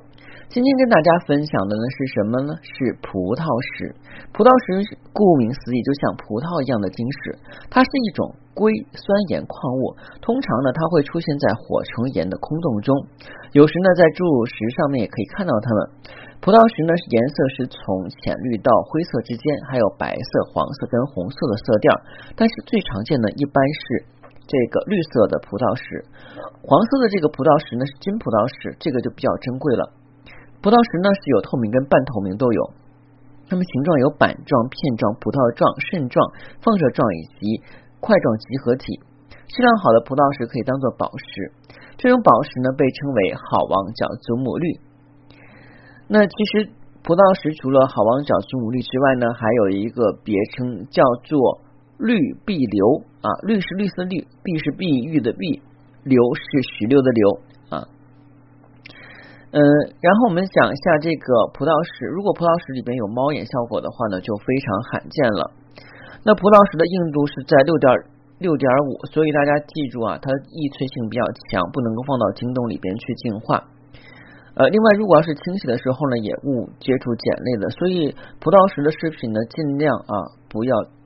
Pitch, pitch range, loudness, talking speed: 140 Hz, 125-170 Hz, -19 LUFS, 265 characters per minute